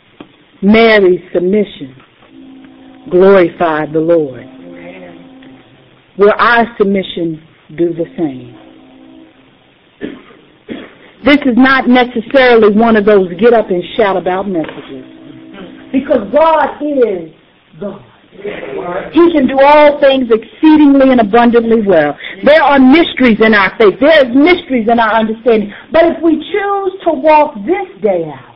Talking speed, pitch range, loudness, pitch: 120 wpm, 170-275 Hz, -9 LUFS, 225 Hz